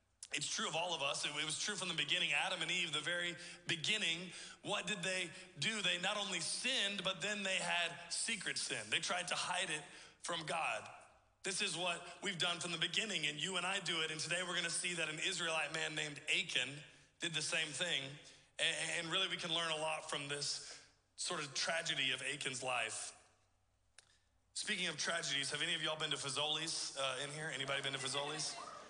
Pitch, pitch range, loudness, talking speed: 165 Hz, 150-180 Hz, -38 LUFS, 210 wpm